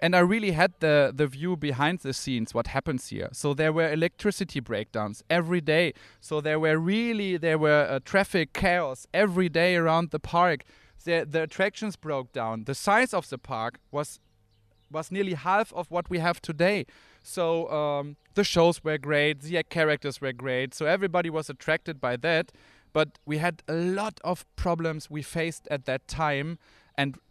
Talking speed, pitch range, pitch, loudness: 180 wpm, 140-175 Hz, 155 Hz, -27 LUFS